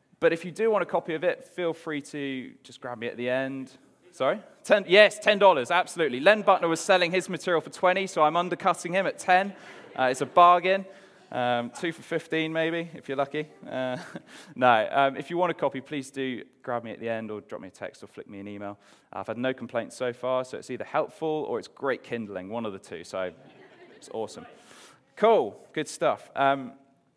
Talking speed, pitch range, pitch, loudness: 220 wpm, 130-180 Hz, 160 Hz, -26 LUFS